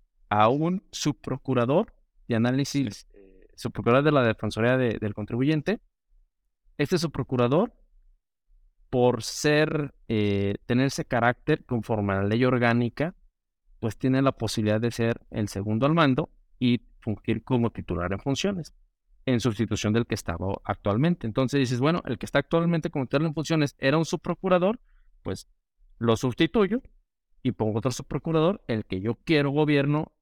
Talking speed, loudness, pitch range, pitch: 145 wpm, -26 LUFS, 110-150 Hz, 125 Hz